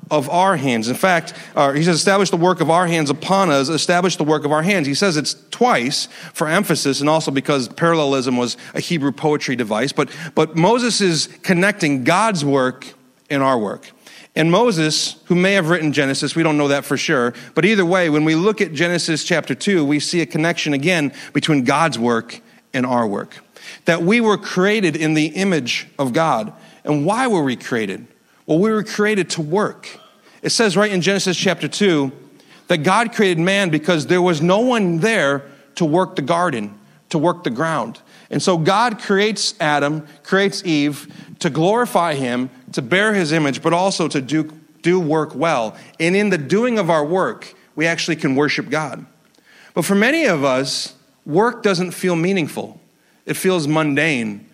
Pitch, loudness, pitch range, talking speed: 165 Hz, -17 LUFS, 145-185 Hz, 190 wpm